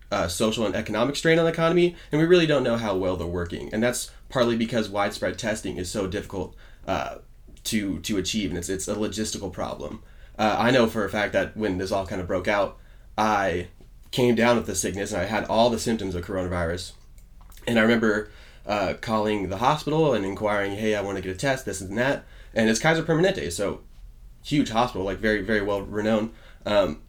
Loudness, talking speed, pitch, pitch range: -25 LUFS, 215 wpm, 105 Hz, 95-120 Hz